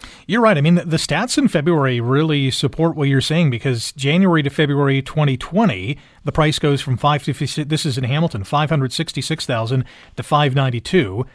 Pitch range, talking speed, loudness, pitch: 135-160 Hz, 165 wpm, -18 LUFS, 145 Hz